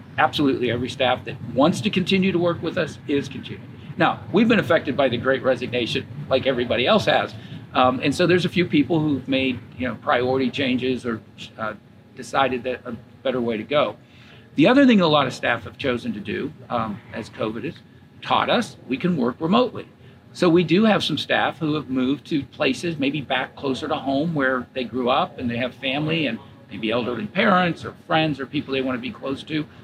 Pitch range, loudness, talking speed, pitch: 125-155 Hz, -22 LUFS, 215 wpm, 135 Hz